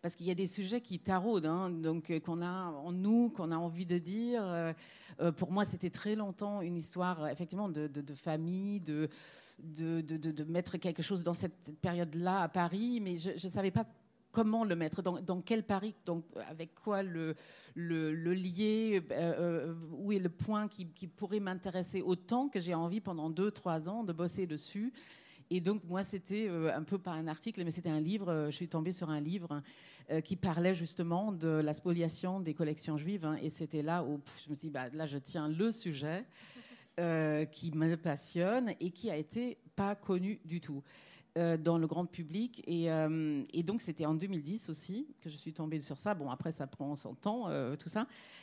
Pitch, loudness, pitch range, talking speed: 175 Hz, -37 LUFS, 160-195 Hz, 205 wpm